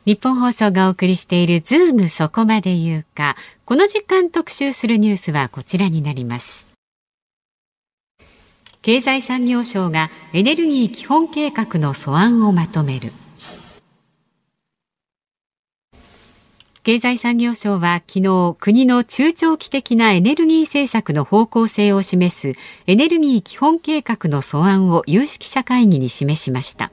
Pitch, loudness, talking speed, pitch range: 210 Hz, -16 LUFS, 265 characters per minute, 170-255 Hz